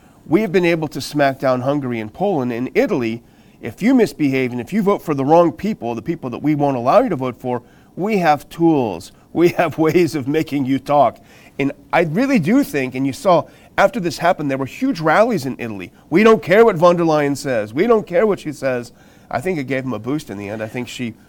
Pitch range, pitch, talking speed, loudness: 130-175 Hz, 145 Hz, 245 wpm, -17 LUFS